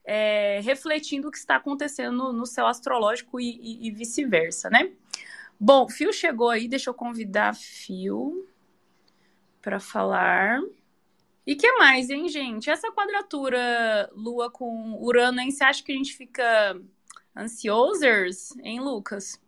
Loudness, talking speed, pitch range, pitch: -24 LUFS, 140 wpm, 225-285 Hz, 250 Hz